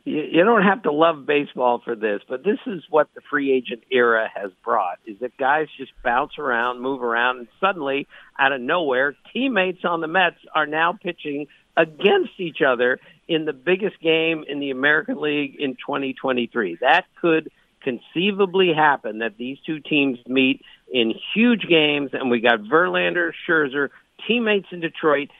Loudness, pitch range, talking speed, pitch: -21 LUFS, 130-175 Hz, 170 wpm, 150 Hz